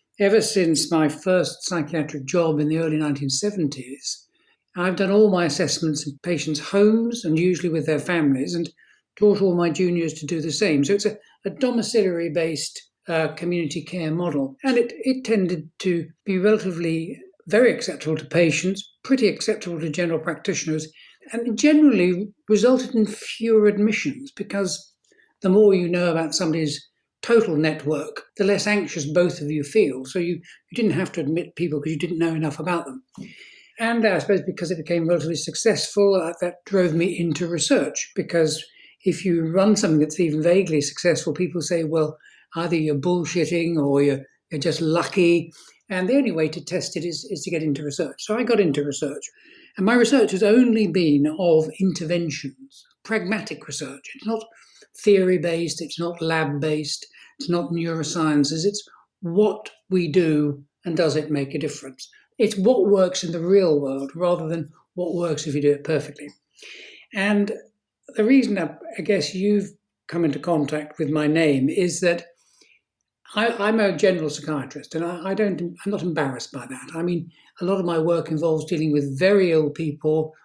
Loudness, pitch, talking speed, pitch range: -22 LUFS, 170 Hz, 175 wpm, 155-200 Hz